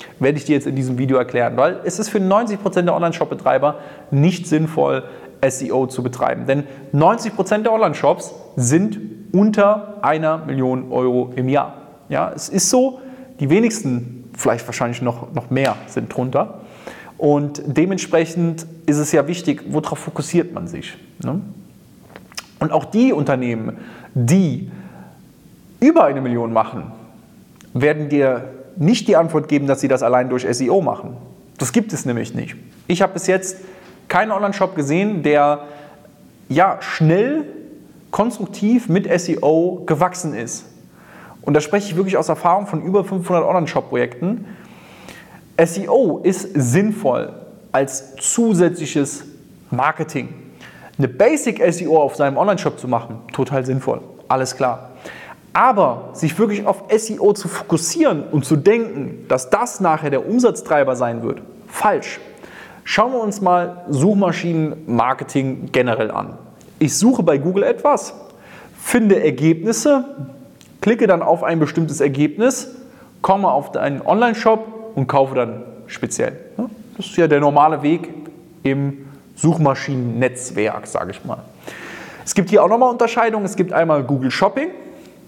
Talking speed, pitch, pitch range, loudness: 135 wpm, 160 Hz, 135-200 Hz, -18 LUFS